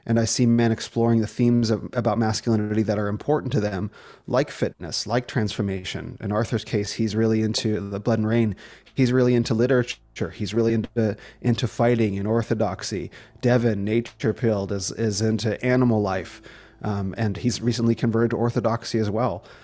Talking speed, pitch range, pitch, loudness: 175 wpm, 105-120 Hz, 115 Hz, -23 LUFS